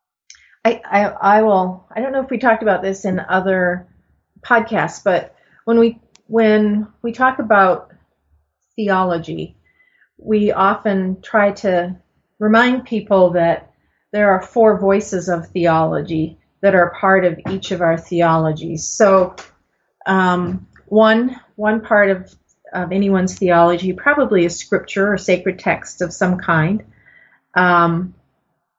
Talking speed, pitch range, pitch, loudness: 130 wpm, 180-215 Hz, 190 Hz, -16 LUFS